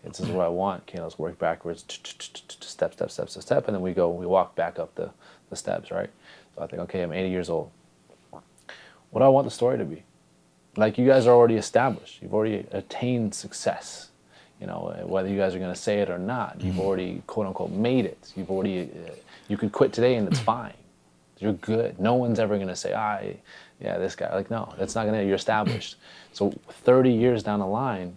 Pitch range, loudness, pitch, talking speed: 90-115 Hz, -26 LUFS, 100 Hz, 225 wpm